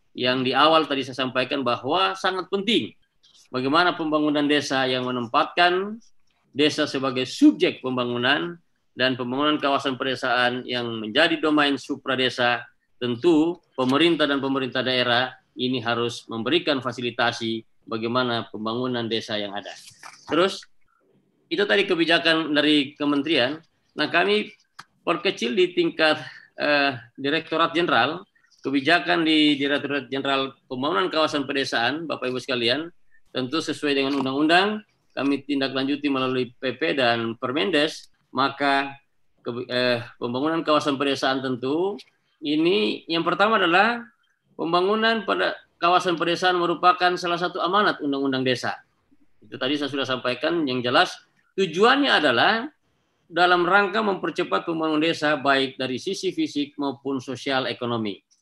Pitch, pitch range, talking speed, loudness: 140 Hz, 130-170 Hz, 120 wpm, -22 LUFS